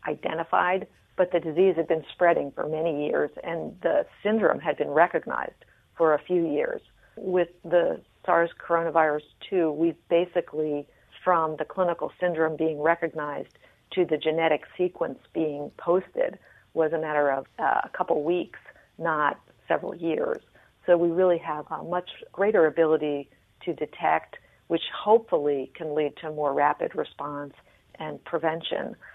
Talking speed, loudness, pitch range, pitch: 145 wpm, -26 LUFS, 150-175 Hz, 165 Hz